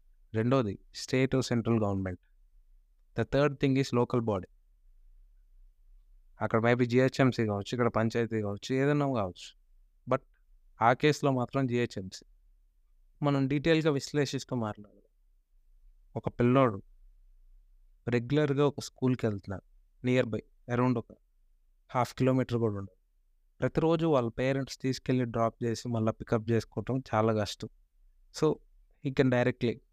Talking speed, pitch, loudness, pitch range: 110 wpm, 115 Hz, -30 LUFS, 95-130 Hz